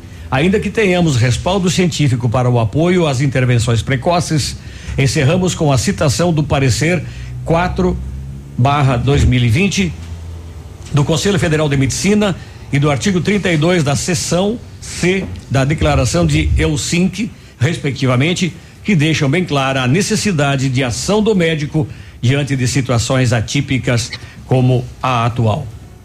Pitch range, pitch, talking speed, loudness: 120-170 Hz, 140 Hz, 120 wpm, -15 LUFS